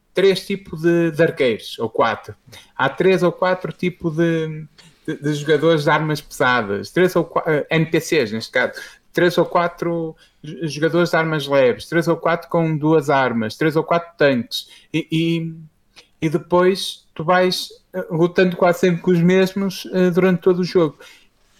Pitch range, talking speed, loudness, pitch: 155-180 Hz, 165 wpm, -19 LUFS, 165 Hz